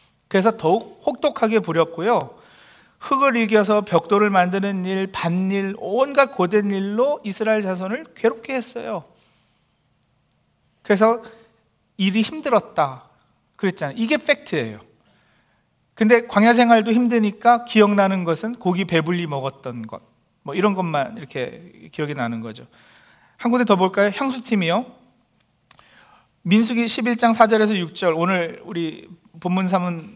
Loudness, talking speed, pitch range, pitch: -20 LUFS, 270 characters per minute, 180-235 Hz, 210 Hz